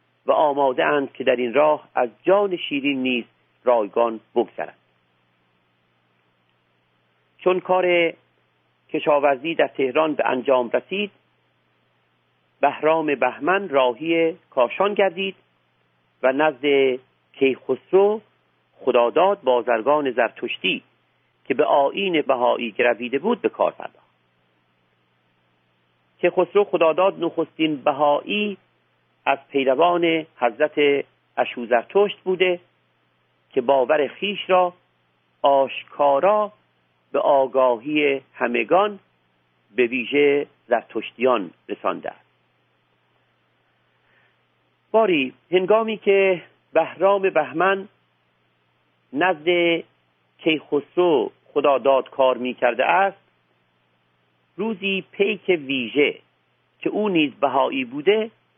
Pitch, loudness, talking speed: 130 Hz, -21 LUFS, 85 wpm